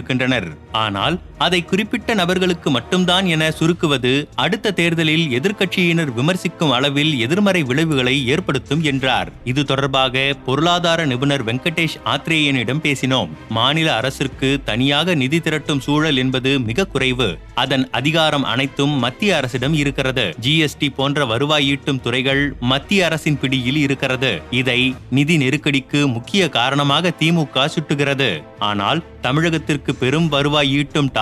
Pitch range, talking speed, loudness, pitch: 130-160 Hz, 115 wpm, -17 LUFS, 145 Hz